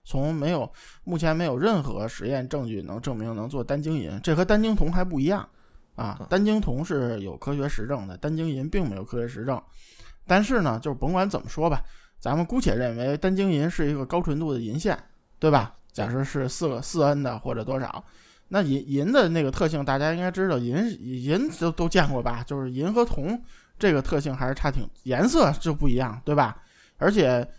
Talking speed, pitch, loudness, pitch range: 300 characters per minute, 145 Hz, -26 LUFS, 130-170 Hz